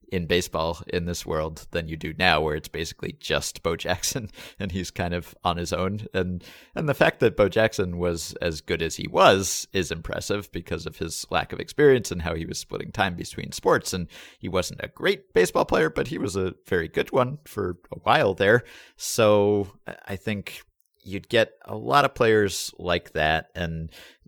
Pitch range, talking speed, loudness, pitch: 85-100 Hz, 200 wpm, -25 LUFS, 90 Hz